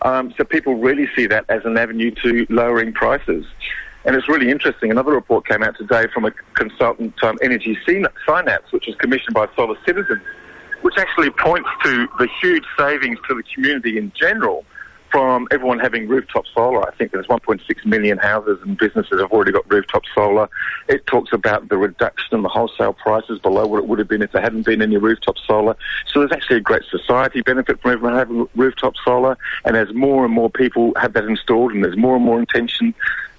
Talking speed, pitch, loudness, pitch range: 200 wpm, 125 Hz, -17 LUFS, 115-135 Hz